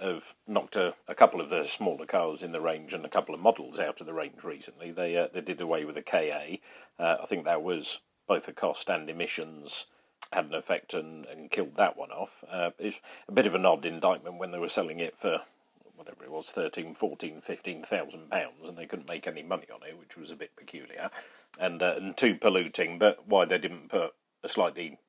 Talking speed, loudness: 225 wpm, -31 LUFS